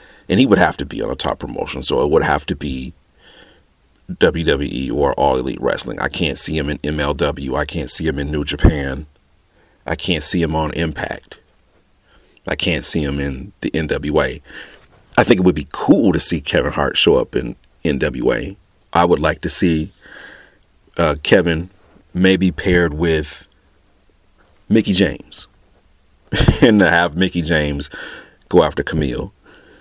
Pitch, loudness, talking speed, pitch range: 80 Hz, -17 LUFS, 165 wpm, 70-90 Hz